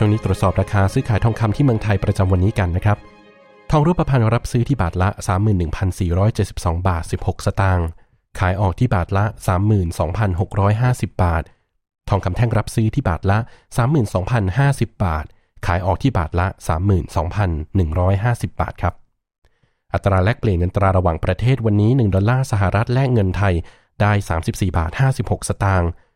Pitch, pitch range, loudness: 100 Hz, 95-115 Hz, -19 LUFS